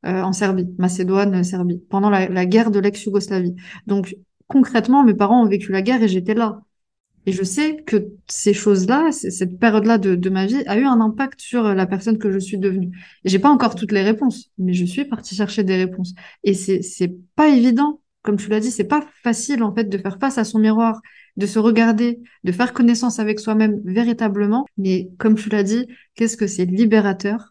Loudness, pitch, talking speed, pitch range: -18 LUFS, 210 Hz, 215 wpm, 190-230 Hz